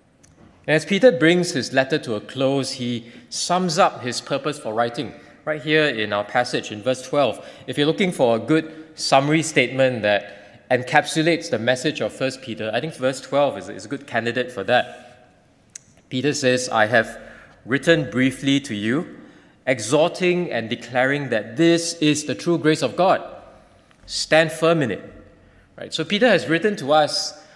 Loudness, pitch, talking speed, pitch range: -20 LUFS, 140 Hz, 170 wpm, 125-160 Hz